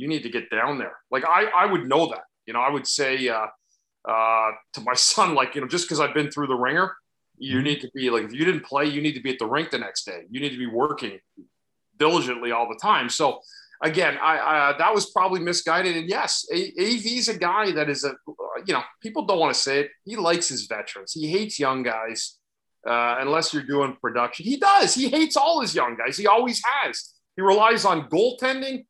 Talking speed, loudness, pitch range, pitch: 235 wpm, -23 LUFS, 130-215 Hz, 155 Hz